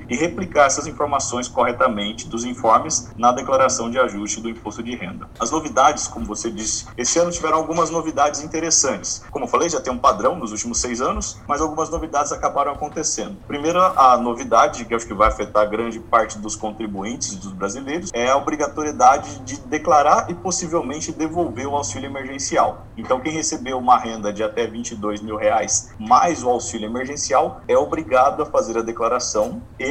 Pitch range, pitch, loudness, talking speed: 115-150 Hz, 125 Hz, -20 LUFS, 180 wpm